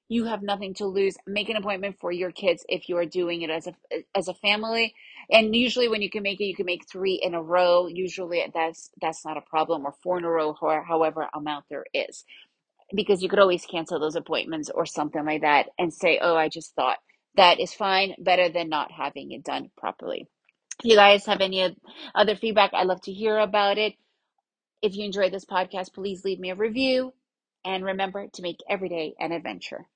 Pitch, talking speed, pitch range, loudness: 190 Hz, 220 wpm, 170-210 Hz, -25 LUFS